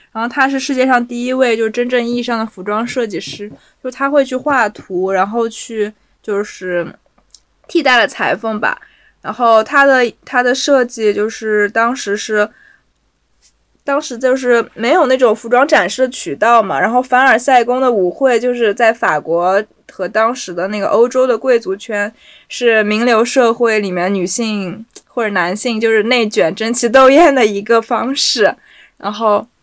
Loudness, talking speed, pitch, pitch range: -13 LUFS, 250 characters per minute, 230 Hz, 210-255 Hz